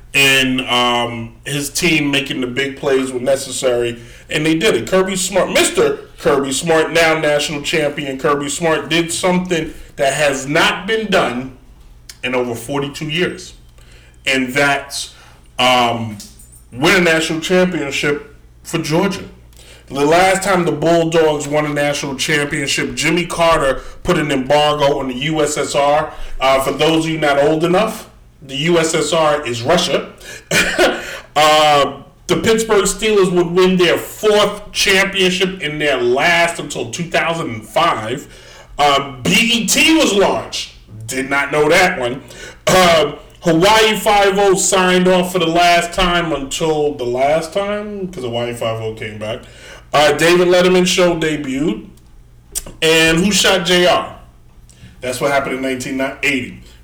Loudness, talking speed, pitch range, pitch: -15 LUFS, 135 wpm, 130-175 Hz, 150 Hz